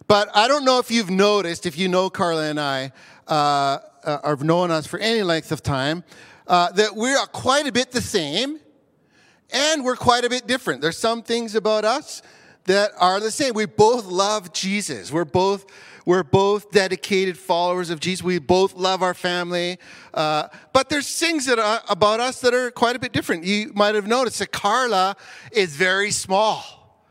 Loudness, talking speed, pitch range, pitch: -20 LUFS, 190 wpm, 175-230 Hz, 195 Hz